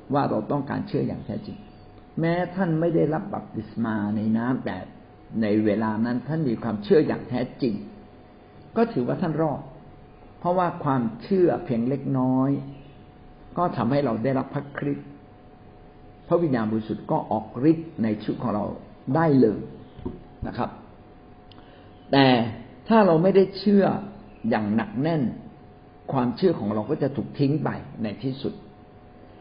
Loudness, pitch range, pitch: -25 LUFS, 110-160 Hz, 135 Hz